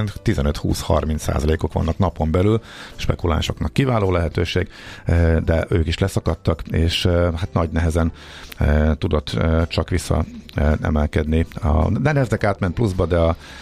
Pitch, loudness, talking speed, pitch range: 85 Hz, -20 LUFS, 110 wpm, 80-100 Hz